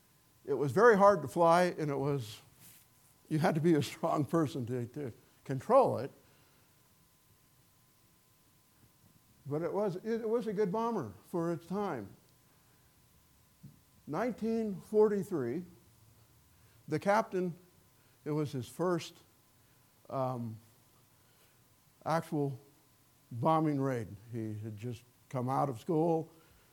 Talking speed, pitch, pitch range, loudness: 110 wpm, 145 Hz, 125-175 Hz, -33 LUFS